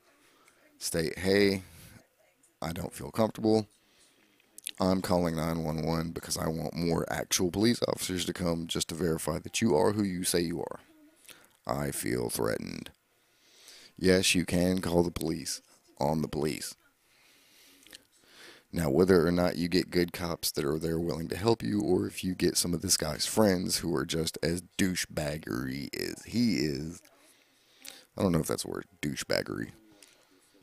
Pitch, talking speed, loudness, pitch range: 90 Hz, 160 wpm, -30 LUFS, 85-100 Hz